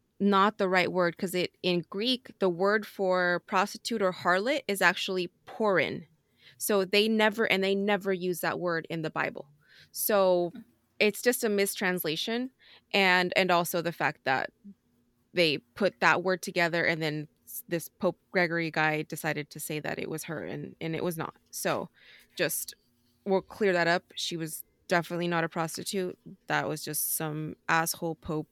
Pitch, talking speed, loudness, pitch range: 180 Hz, 170 wpm, -28 LUFS, 165-200 Hz